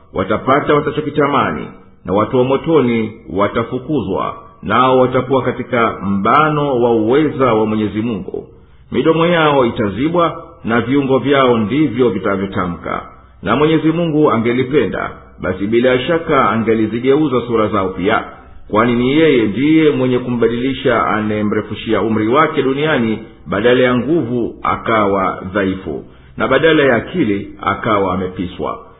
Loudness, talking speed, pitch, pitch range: -15 LUFS, 115 wpm, 120 Hz, 105-135 Hz